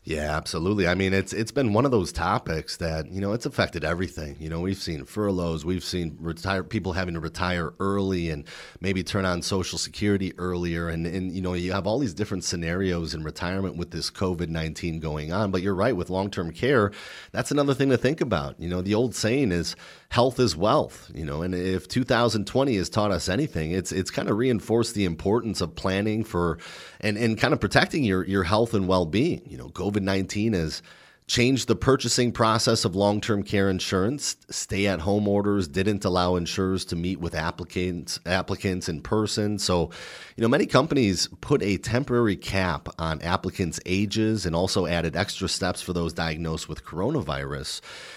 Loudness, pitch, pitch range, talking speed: -26 LUFS, 95 Hz, 85-105 Hz, 185 wpm